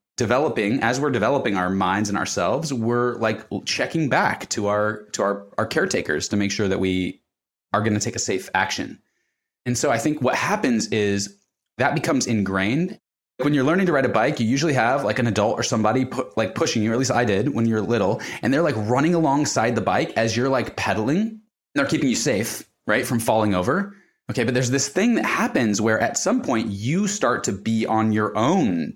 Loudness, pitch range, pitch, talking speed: -22 LUFS, 105-135 Hz, 115 Hz, 220 wpm